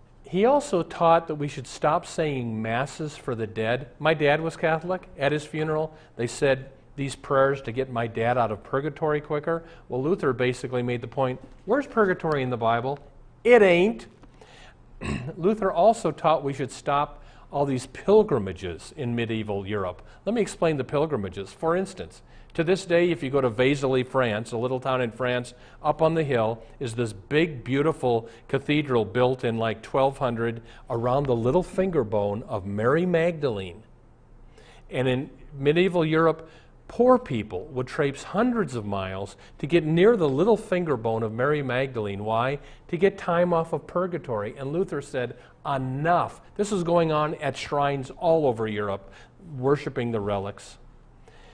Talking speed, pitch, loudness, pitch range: 165 wpm, 135 Hz, -25 LUFS, 120-160 Hz